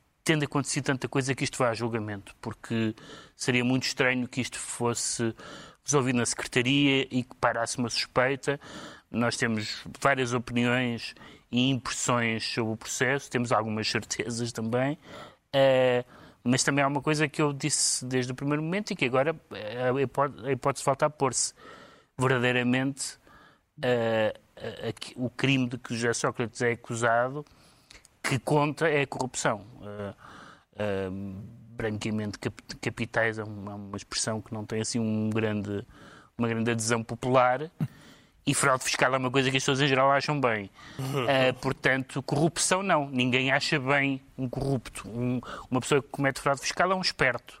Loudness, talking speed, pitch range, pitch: -28 LUFS, 155 wpm, 115-140 Hz, 125 Hz